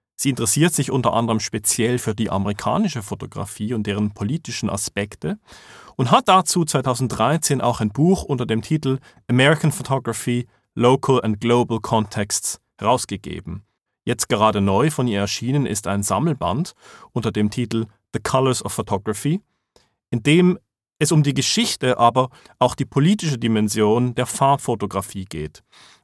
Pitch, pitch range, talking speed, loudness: 120 Hz, 110-140 Hz, 140 wpm, -20 LUFS